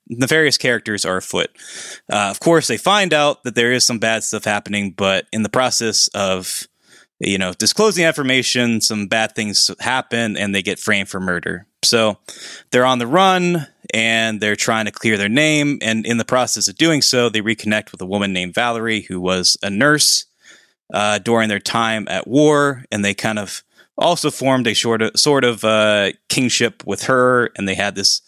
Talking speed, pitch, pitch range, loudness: 195 wpm, 115 Hz, 105-130 Hz, -16 LUFS